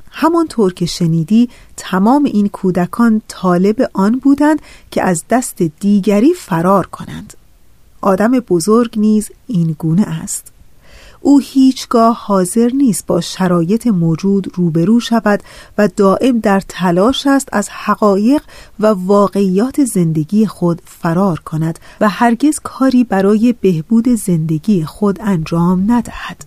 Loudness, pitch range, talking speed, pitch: -13 LUFS, 185-235 Hz, 120 wpm, 205 Hz